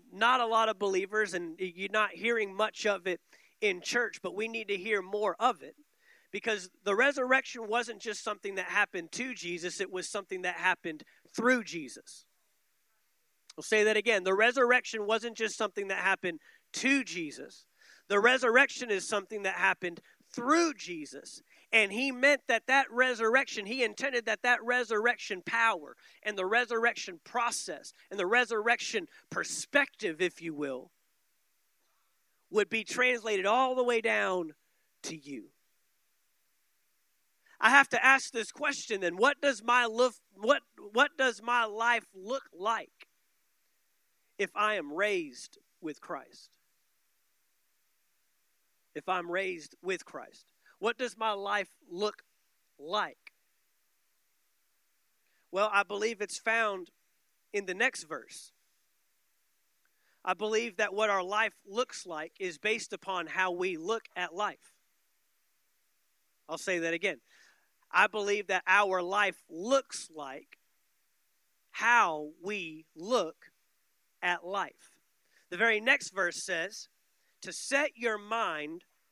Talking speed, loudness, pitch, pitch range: 135 wpm, -30 LUFS, 215 Hz, 190-245 Hz